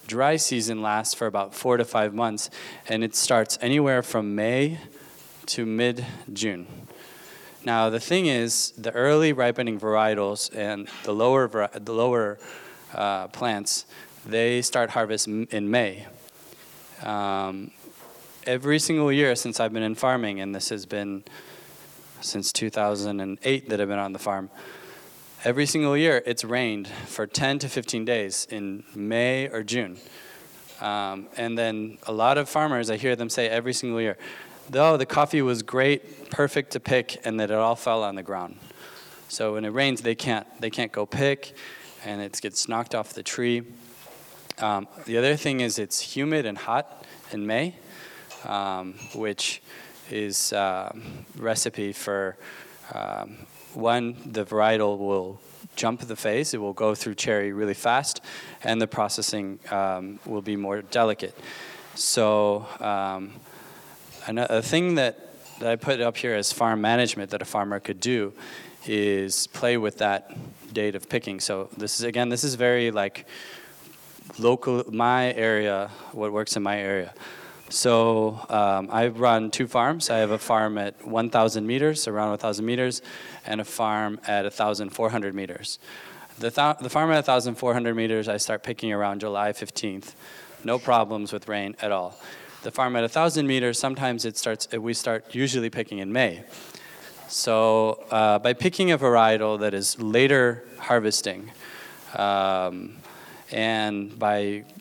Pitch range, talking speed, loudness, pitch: 105-125 Hz, 155 wpm, -25 LUFS, 110 Hz